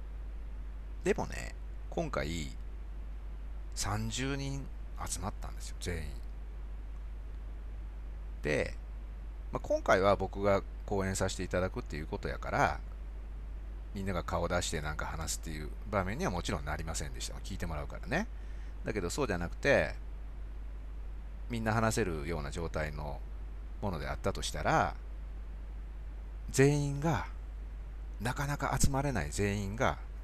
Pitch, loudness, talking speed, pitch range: 75 Hz, -35 LUFS, 260 characters per minute, 60-95 Hz